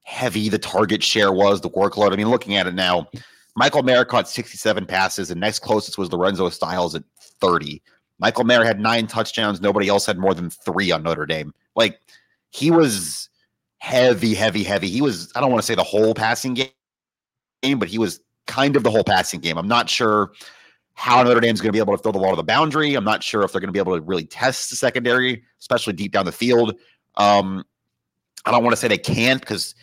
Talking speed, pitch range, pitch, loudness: 220 wpm, 95-115 Hz, 105 Hz, -19 LUFS